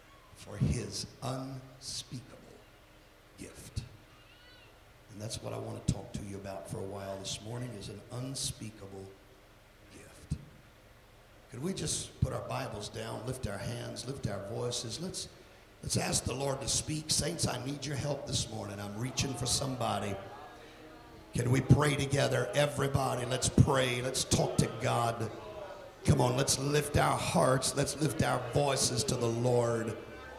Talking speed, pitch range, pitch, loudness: 155 wpm, 105-135 Hz, 125 Hz, -33 LUFS